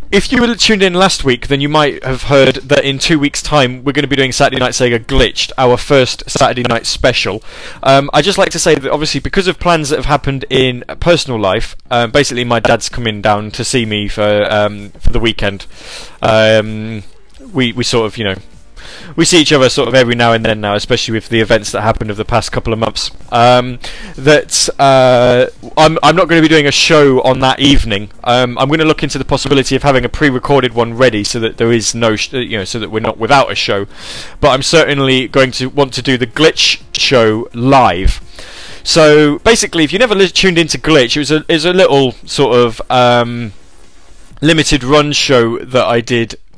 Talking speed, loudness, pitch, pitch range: 225 wpm, -11 LUFS, 130 Hz, 115-145 Hz